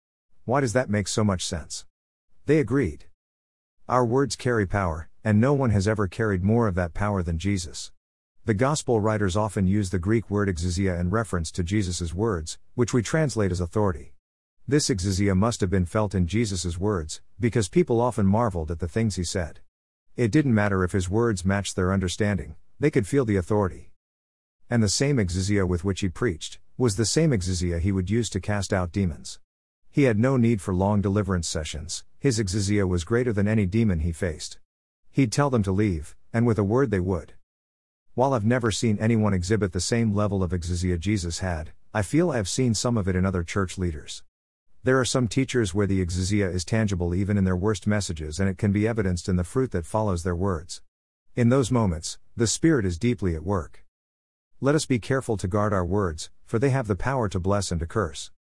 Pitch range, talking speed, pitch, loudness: 90-115 Hz, 205 wpm, 100 Hz, -25 LUFS